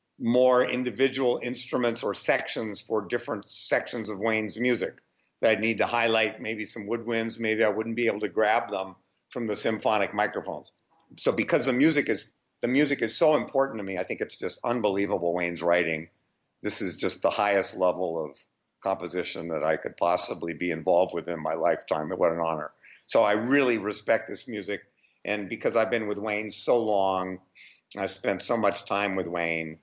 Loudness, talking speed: -27 LUFS, 185 wpm